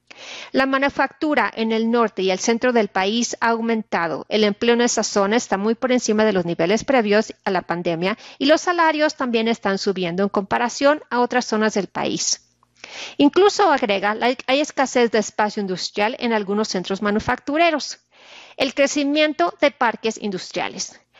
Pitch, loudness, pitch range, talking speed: 230 Hz, -20 LUFS, 205-270 Hz, 165 wpm